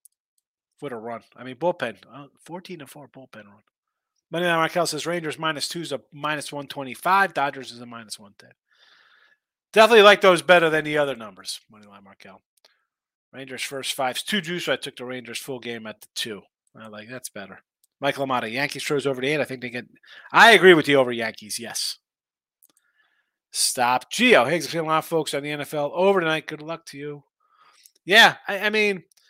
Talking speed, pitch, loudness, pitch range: 195 wpm, 145 Hz, -20 LUFS, 125-170 Hz